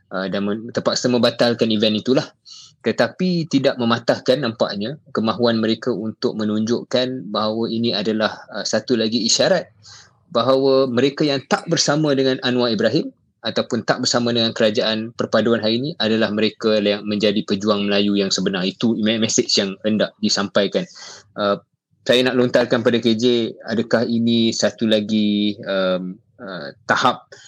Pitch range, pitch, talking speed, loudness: 105-125 Hz, 115 Hz, 140 wpm, -19 LUFS